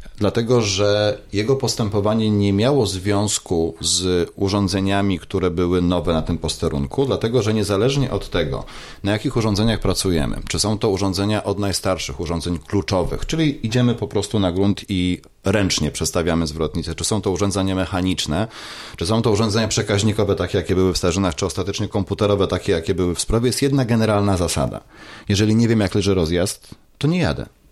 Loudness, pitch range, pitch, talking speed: -20 LUFS, 90-110 Hz, 100 Hz, 170 wpm